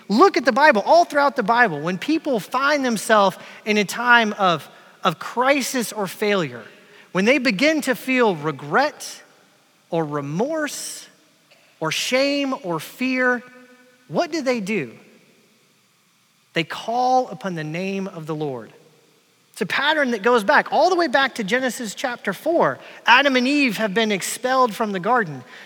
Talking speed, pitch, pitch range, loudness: 155 wpm, 230 Hz, 190-260 Hz, -20 LUFS